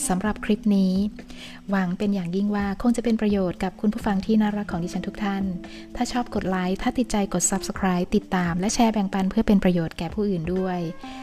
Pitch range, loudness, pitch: 185-210 Hz, -24 LUFS, 195 Hz